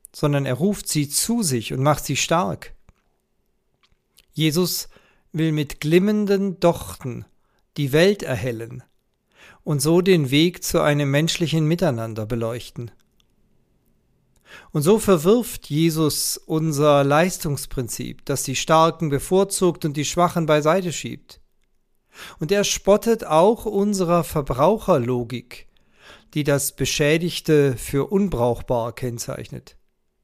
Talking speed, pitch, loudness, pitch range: 105 wpm, 155 Hz, -20 LUFS, 135-180 Hz